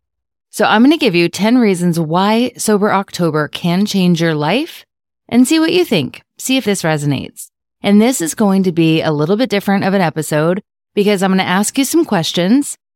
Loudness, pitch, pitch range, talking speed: -14 LUFS, 195 Hz, 170-230 Hz, 210 wpm